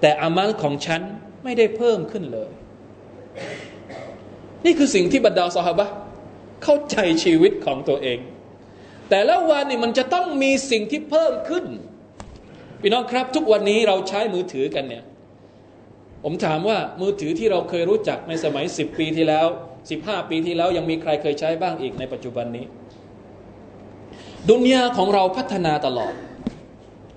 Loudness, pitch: -21 LUFS, 180 Hz